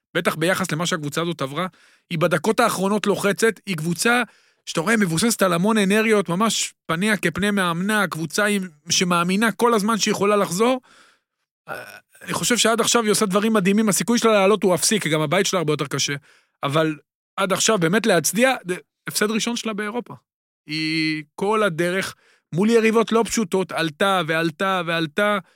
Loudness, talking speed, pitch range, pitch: -20 LUFS, 160 wpm, 170-220 Hz, 195 Hz